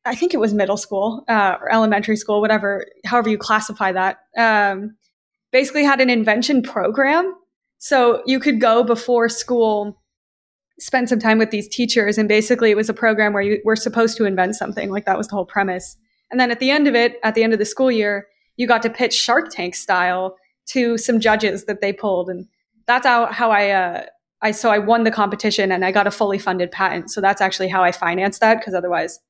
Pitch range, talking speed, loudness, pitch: 200-235 Hz, 220 wpm, -18 LUFS, 215 Hz